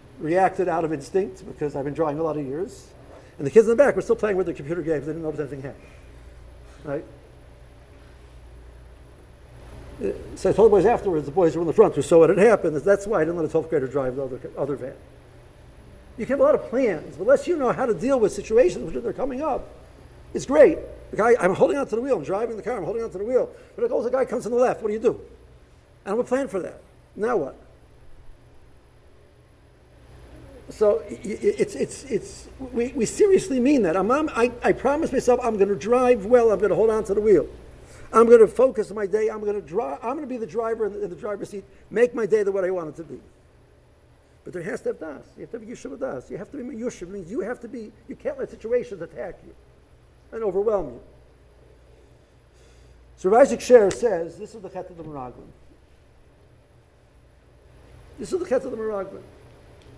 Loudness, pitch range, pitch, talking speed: -22 LUFS, 160-260 Hz, 215 Hz, 220 wpm